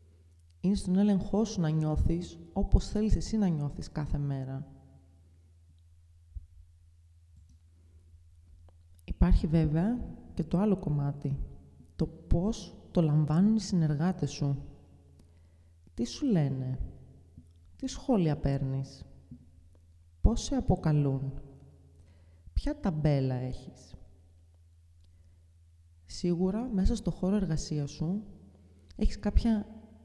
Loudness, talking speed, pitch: -31 LUFS, 90 wpm, 120 Hz